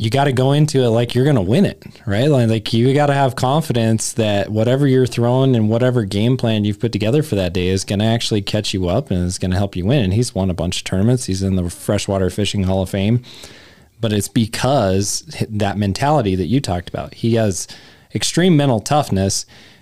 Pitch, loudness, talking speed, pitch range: 110 Hz, -17 LUFS, 220 wpm, 95-125 Hz